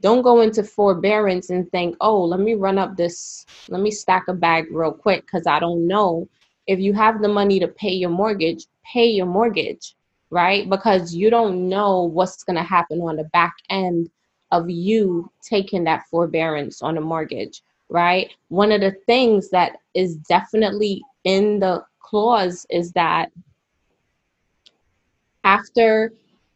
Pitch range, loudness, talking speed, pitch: 170-210 Hz, -19 LUFS, 160 wpm, 185 Hz